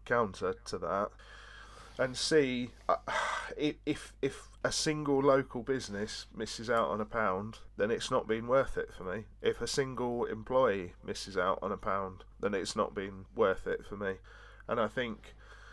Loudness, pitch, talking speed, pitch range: -34 LUFS, 120 Hz, 170 wpm, 100-135 Hz